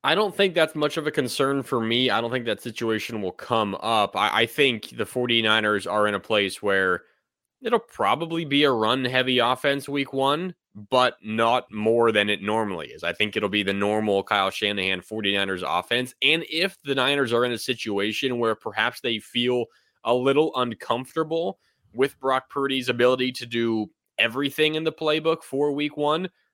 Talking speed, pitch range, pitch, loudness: 185 wpm, 110-145 Hz, 125 Hz, -23 LUFS